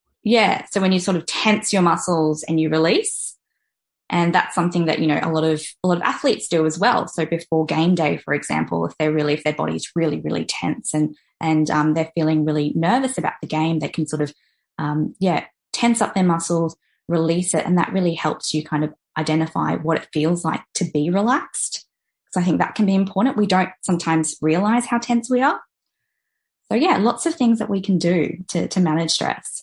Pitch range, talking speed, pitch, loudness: 155-195 Hz, 220 wpm, 165 Hz, -20 LUFS